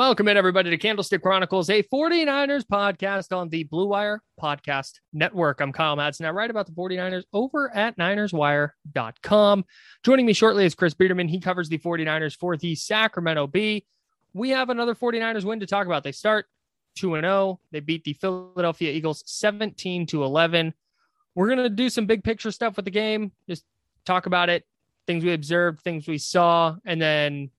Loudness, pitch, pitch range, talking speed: -23 LUFS, 185 Hz, 165-210 Hz, 175 wpm